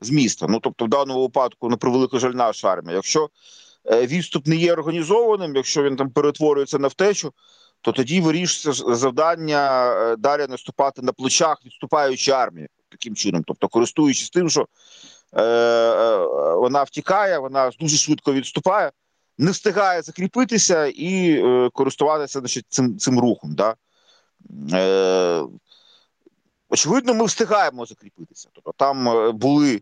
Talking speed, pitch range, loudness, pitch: 135 wpm, 125-170 Hz, -20 LUFS, 145 Hz